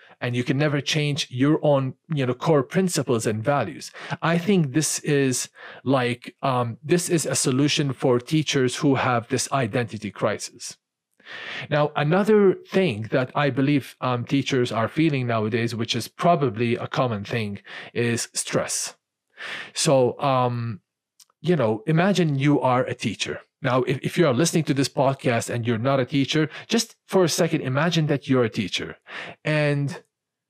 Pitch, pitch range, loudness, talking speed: 140 Hz, 125-155 Hz, -23 LUFS, 160 wpm